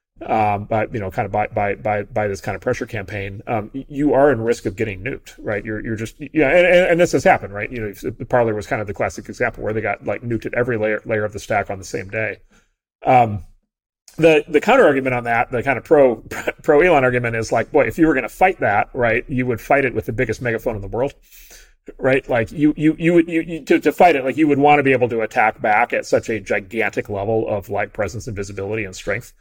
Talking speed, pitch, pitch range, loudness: 270 wpm, 115 Hz, 105-145 Hz, -18 LUFS